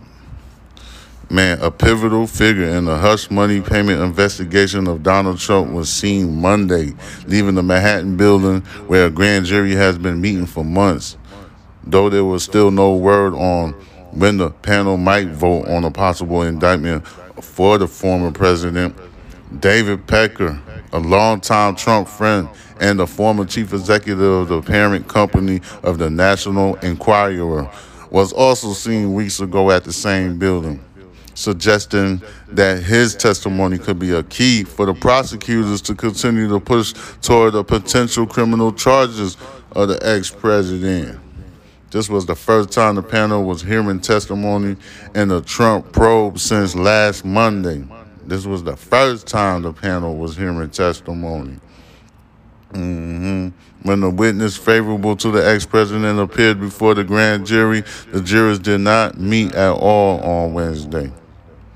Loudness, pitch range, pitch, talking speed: -16 LUFS, 90-105 Hz, 100 Hz, 145 wpm